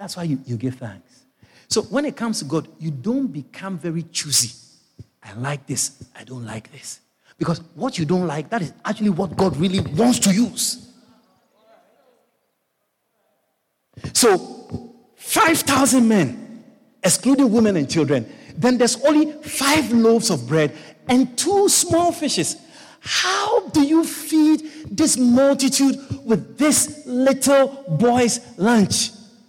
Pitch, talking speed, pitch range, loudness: 230 Hz, 135 wpm, 165-270 Hz, -19 LUFS